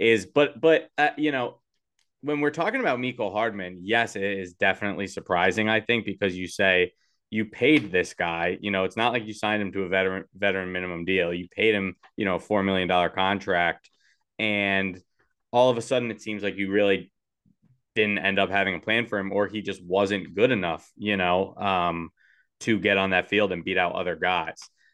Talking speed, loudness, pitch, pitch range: 210 wpm, -25 LUFS, 100 Hz, 95-110 Hz